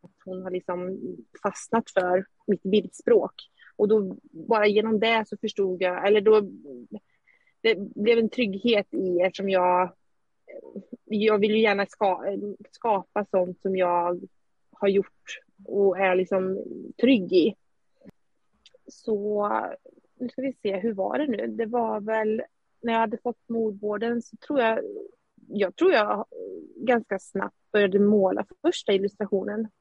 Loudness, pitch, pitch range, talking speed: -25 LUFS, 210 Hz, 195-230 Hz, 140 wpm